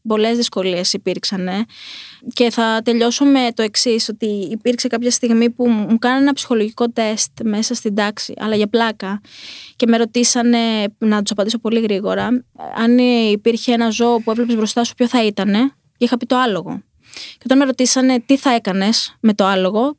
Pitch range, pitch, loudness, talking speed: 215-245 Hz, 230 Hz, -16 LUFS, 175 wpm